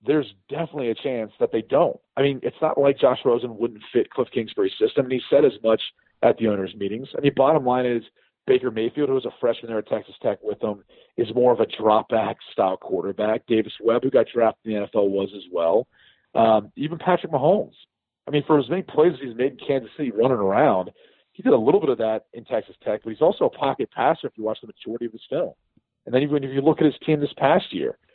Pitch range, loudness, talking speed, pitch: 110-160 Hz, -22 LUFS, 255 wpm, 130 Hz